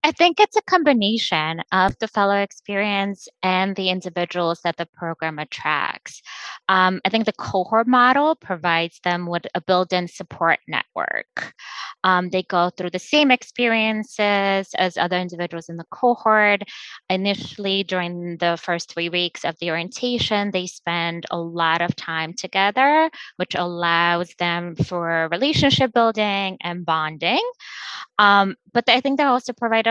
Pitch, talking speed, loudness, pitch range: 185 Hz, 150 wpm, -20 LUFS, 175-220 Hz